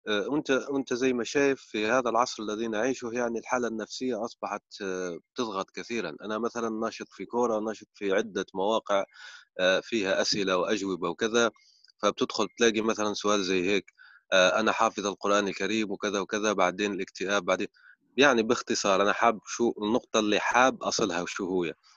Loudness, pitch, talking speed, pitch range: -28 LUFS, 110 Hz, 150 wpm, 100-120 Hz